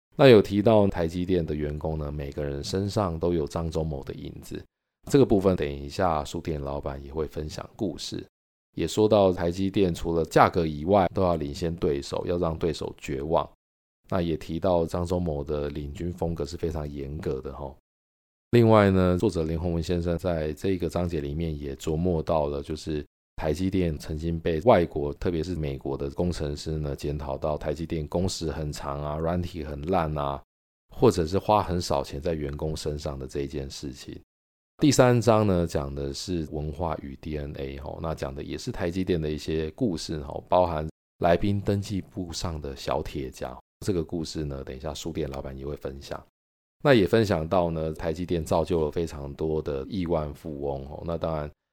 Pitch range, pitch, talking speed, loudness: 70-90 Hz, 80 Hz, 275 characters per minute, -27 LUFS